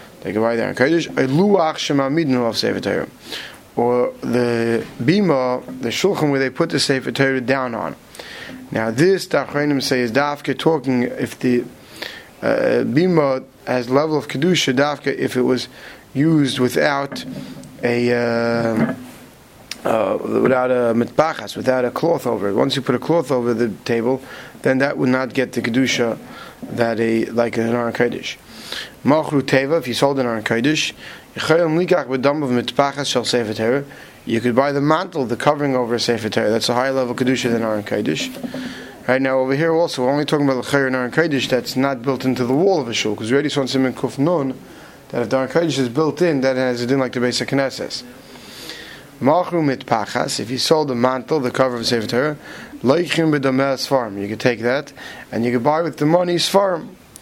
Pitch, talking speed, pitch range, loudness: 130 Hz, 165 wpm, 120-145 Hz, -19 LUFS